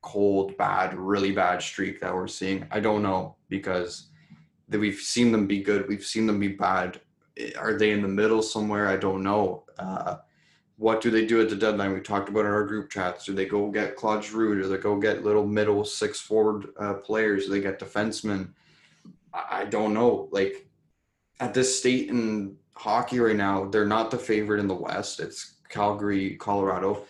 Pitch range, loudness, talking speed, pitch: 100-110 Hz, -26 LUFS, 195 wpm, 105 Hz